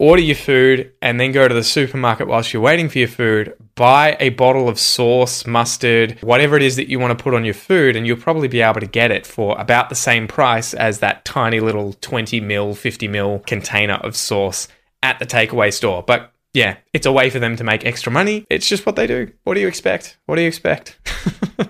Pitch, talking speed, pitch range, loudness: 120 Hz, 230 wpm, 110-130 Hz, -16 LUFS